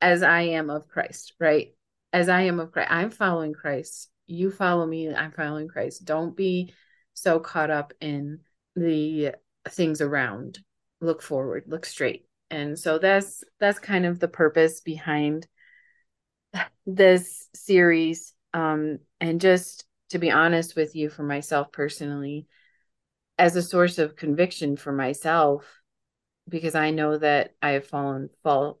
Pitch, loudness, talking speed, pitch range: 160 Hz, -24 LUFS, 145 wpm, 150-175 Hz